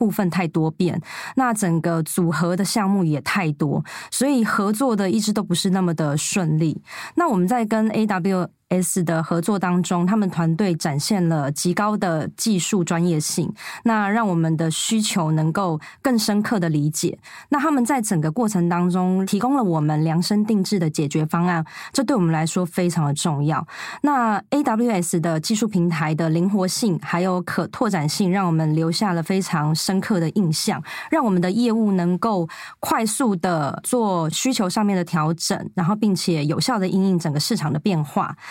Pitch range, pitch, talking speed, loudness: 165-210 Hz, 185 Hz, 275 characters per minute, -21 LUFS